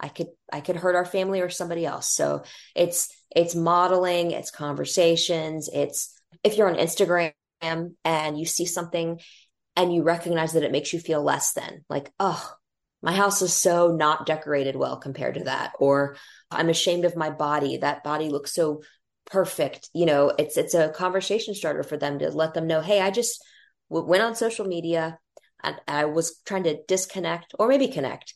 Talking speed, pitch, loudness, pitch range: 185 wpm, 170 Hz, -24 LUFS, 155-180 Hz